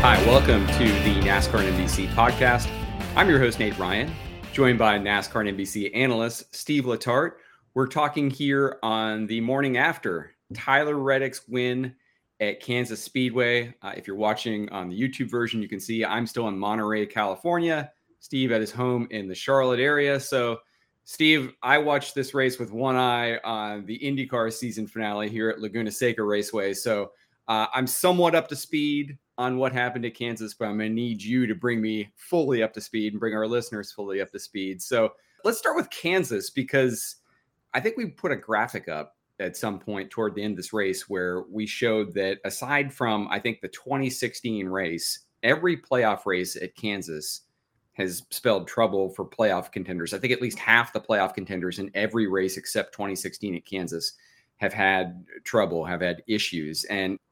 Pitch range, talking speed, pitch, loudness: 100-130 Hz, 180 wpm, 110 Hz, -25 LUFS